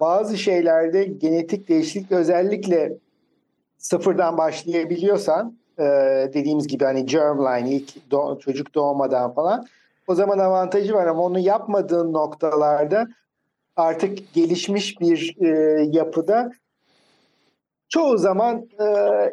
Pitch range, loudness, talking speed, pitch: 155-200 Hz, -20 LUFS, 100 wpm, 175 Hz